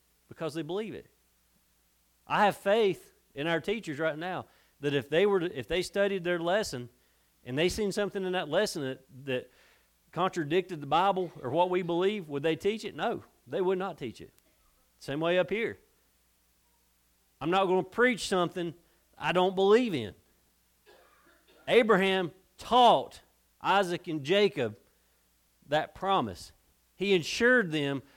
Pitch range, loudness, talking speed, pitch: 125-190 Hz, -29 LUFS, 155 wpm, 170 Hz